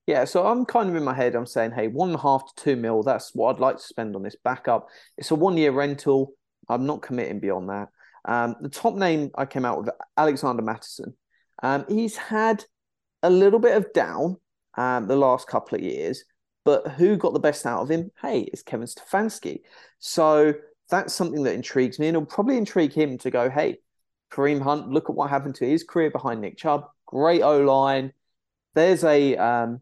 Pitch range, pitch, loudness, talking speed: 135-180 Hz, 150 Hz, -23 LUFS, 210 wpm